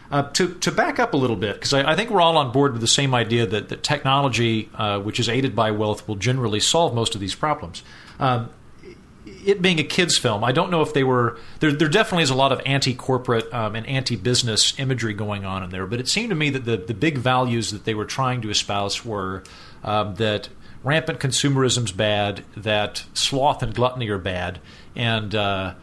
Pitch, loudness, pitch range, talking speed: 120 Hz, -21 LUFS, 105-140 Hz, 225 wpm